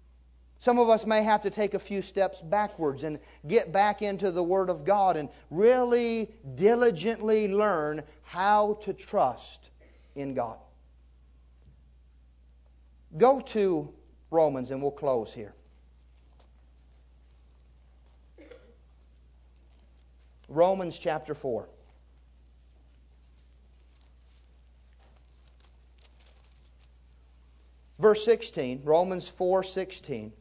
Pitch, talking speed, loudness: 65 Hz, 85 wpm, -27 LUFS